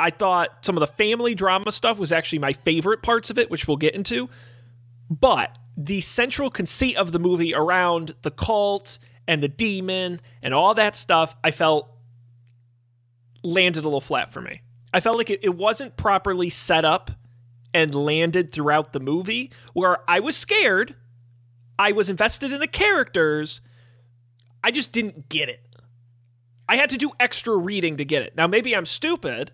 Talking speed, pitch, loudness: 175 wpm, 165 Hz, -21 LUFS